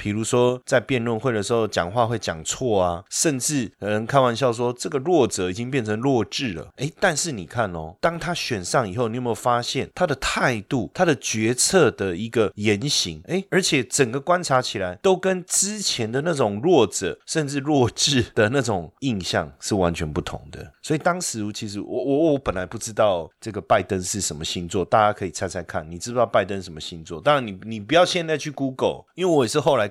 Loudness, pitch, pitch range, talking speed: -22 LUFS, 120 Hz, 95-140 Hz, 325 characters per minute